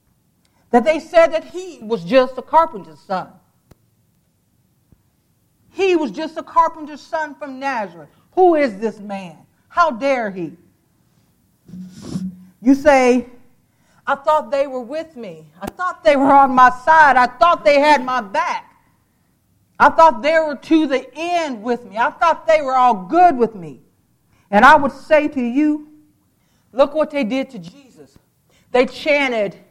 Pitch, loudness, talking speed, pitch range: 280 Hz, -16 LUFS, 155 wpm, 240-315 Hz